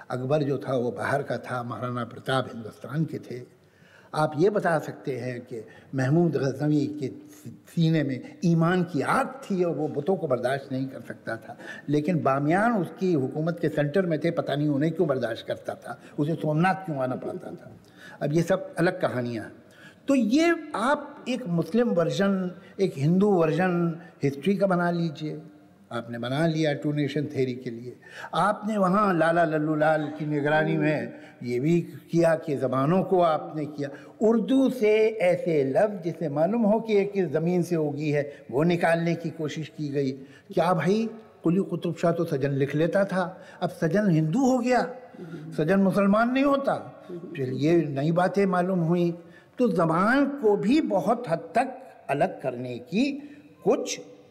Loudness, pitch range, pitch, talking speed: -26 LUFS, 145-195 Hz, 165 Hz, 170 wpm